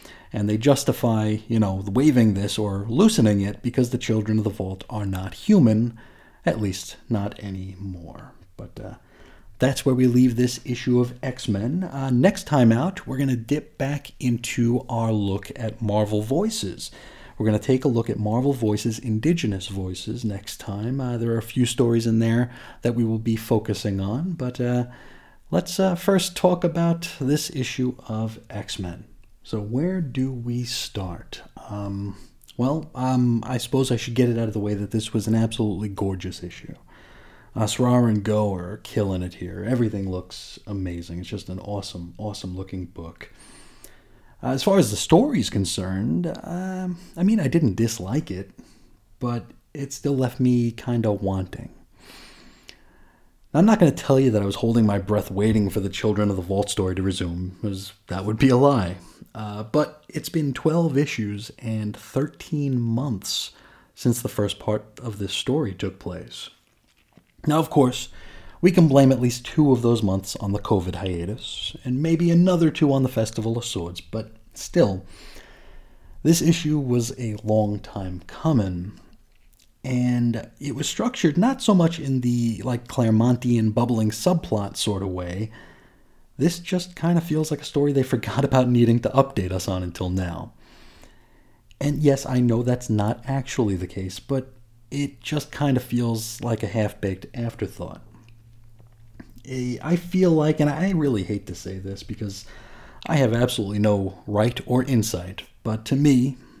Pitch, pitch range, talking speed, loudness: 115 Hz, 105-135 Hz, 175 wpm, -23 LUFS